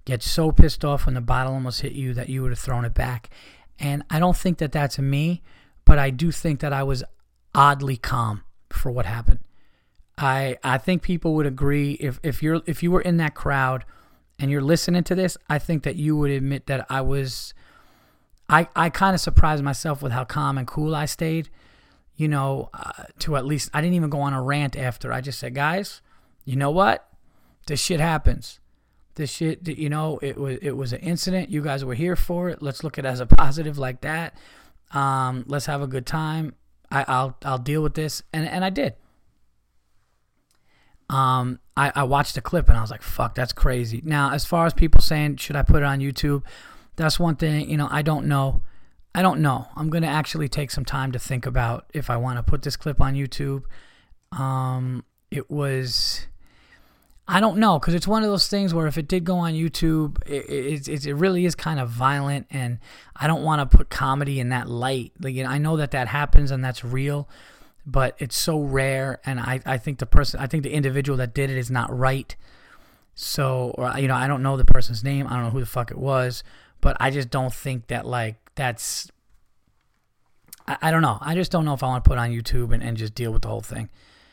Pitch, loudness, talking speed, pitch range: 140 Hz, -24 LUFS, 225 wpm, 130-155 Hz